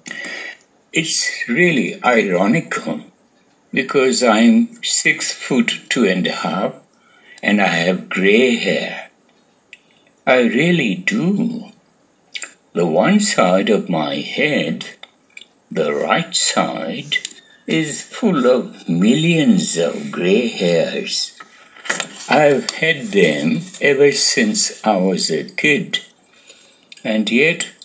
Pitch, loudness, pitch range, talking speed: 215 Hz, -16 LUFS, 200-250 Hz, 100 wpm